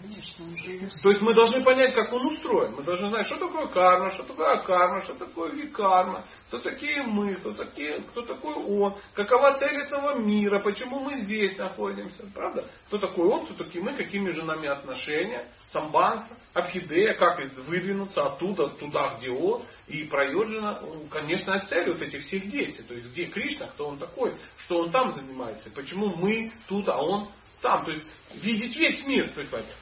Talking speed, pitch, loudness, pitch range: 175 wpm, 200 Hz, -27 LUFS, 175-255 Hz